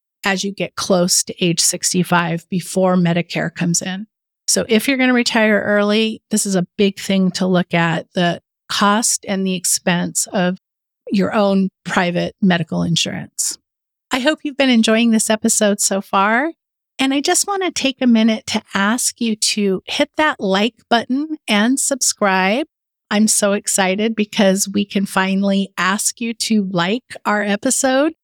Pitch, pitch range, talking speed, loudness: 205 Hz, 185-230 Hz, 165 wpm, -17 LUFS